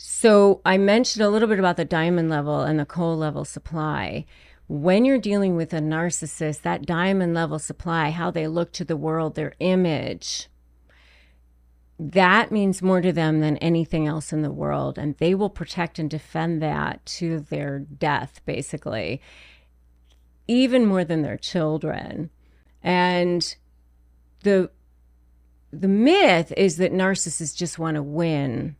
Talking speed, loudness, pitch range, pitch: 150 wpm, -22 LUFS, 135-180 Hz, 160 Hz